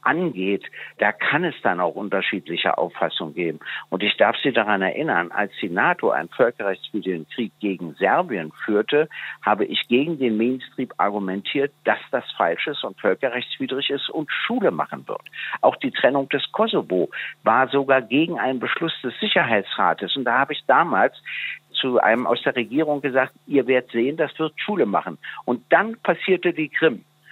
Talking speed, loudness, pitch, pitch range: 165 wpm, -22 LUFS, 135 Hz, 115-150 Hz